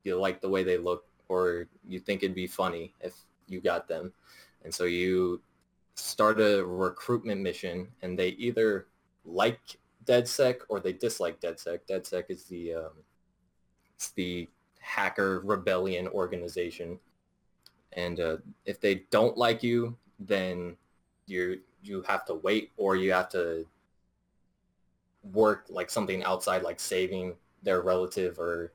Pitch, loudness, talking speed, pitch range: 90 Hz, -30 LUFS, 140 wpm, 85-95 Hz